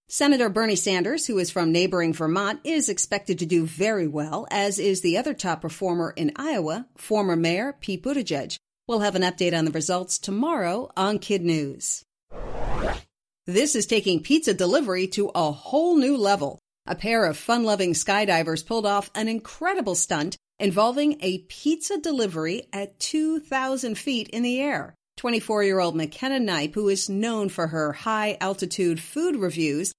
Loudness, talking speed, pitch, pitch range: -24 LUFS, 165 wpm, 200 Hz, 180-240 Hz